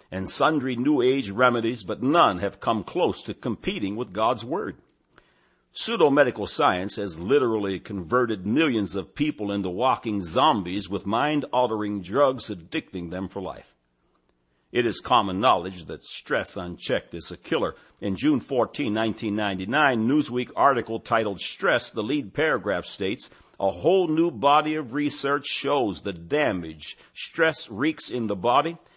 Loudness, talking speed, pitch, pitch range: -24 LUFS, 145 wpm, 110 Hz, 95-130 Hz